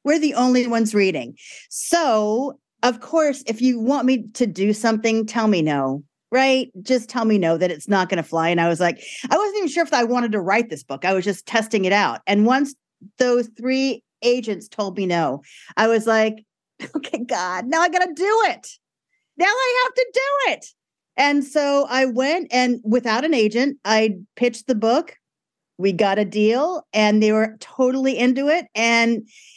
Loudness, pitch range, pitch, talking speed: -20 LUFS, 210-270 Hz, 230 Hz, 200 wpm